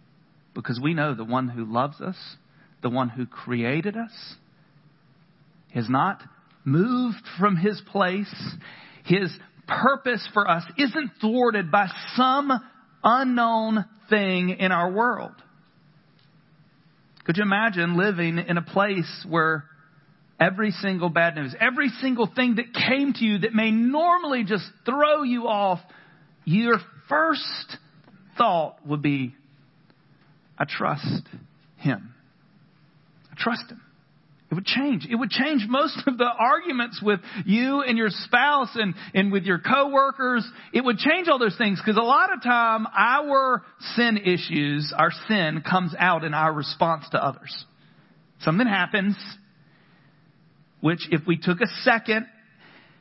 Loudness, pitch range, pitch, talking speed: -23 LUFS, 160-230 Hz, 185 Hz, 135 wpm